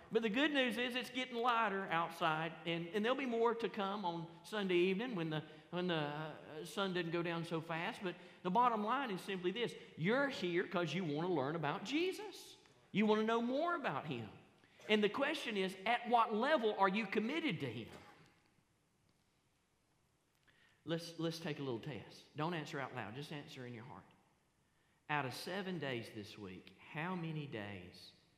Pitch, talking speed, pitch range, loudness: 180 Hz, 185 wpm, 155-225 Hz, -39 LUFS